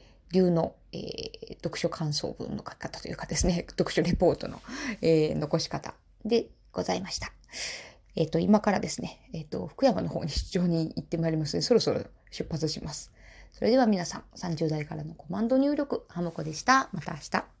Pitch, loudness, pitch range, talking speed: 175 Hz, -29 LUFS, 160-225 Hz, 360 characters per minute